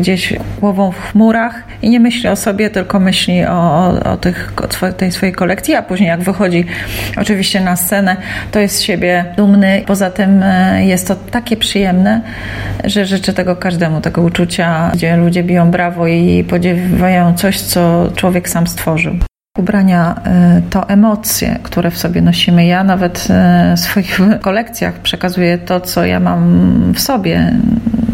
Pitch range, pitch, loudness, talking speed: 170-200 Hz, 185 Hz, -12 LUFS, 155 wpm